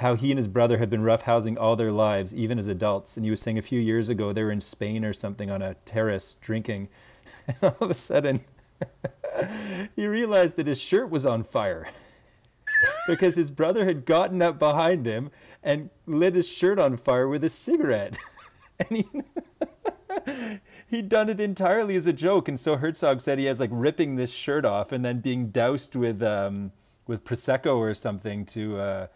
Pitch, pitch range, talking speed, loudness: 135 Hz, 110-180 Hz, 195 wpm, -25 LUFS